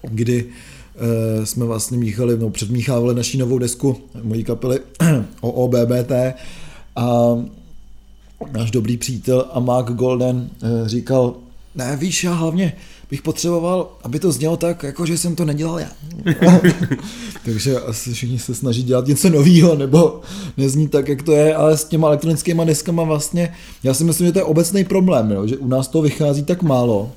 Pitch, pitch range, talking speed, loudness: 135 Hz, 120-165 Hz, 165 wpm, -17 LUFS